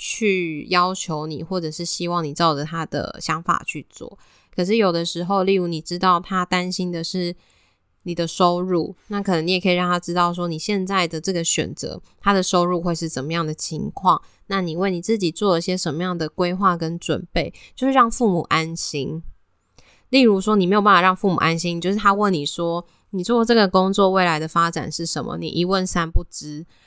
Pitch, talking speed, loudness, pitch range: 175 Hz, 300 characters per minute, -21 LUFS, 165-190 Hz